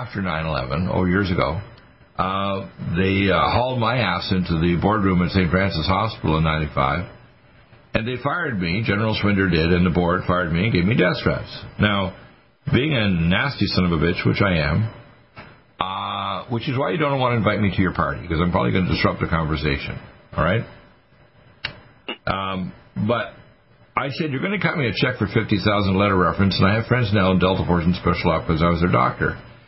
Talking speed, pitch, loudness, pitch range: 210 wpm, 95 Hz, -21 LUFS, 90-115 Hz